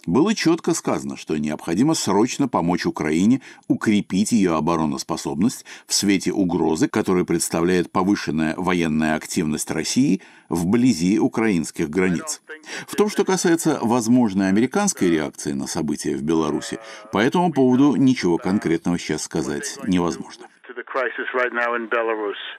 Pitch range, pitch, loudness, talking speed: 85-130 Hz, 105 Hz, -21 LUFS, 110 wpm